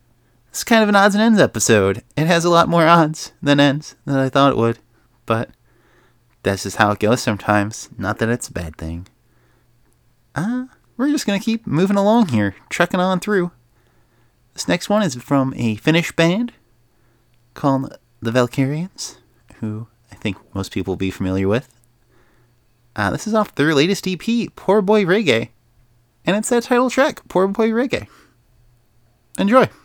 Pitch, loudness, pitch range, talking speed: 130 Hz, -18 LUFS, 115-185 Hz, 170 wpm